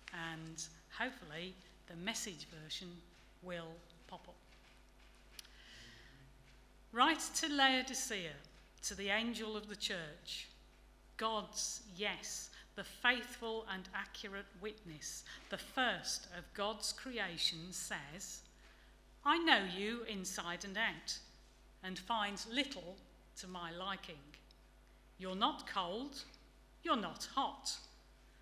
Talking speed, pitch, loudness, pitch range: 100 wpm, 190 Hz, -40 LUFS, 160-220 Hz